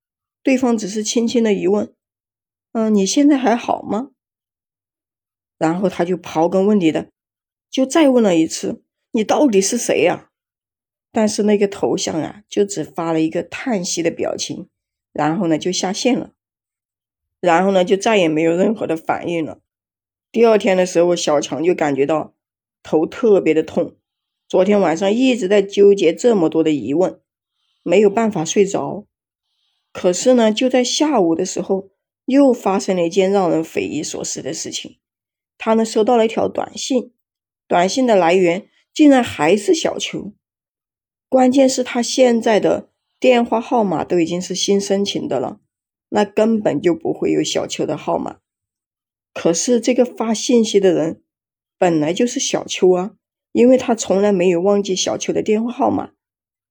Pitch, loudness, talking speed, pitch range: 200 Hz, -17 LUFS, 235 characters per minute, 170-235 Hz